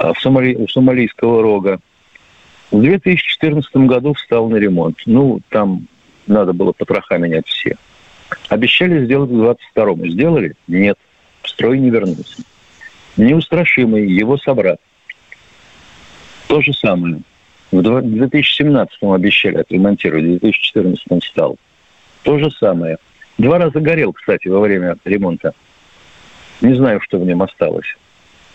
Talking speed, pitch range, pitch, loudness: 120 wpm, 95-140 Hz, 115 Hz, -13 LUFS